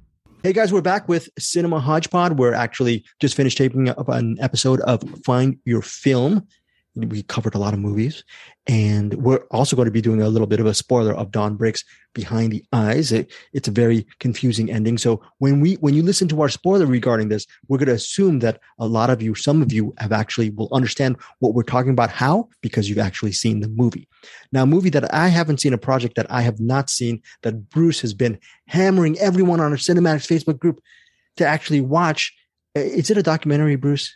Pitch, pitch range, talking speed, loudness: 130 Hz, 115-155 Hz, 215 wpm, -19 LUFS